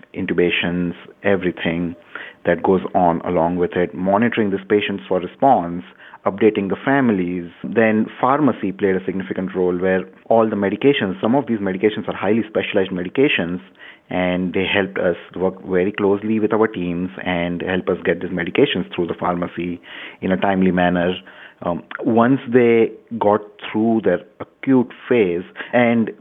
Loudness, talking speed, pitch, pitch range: -19 LUFS, 150 wpm, 95 Hz, 90-110 Hz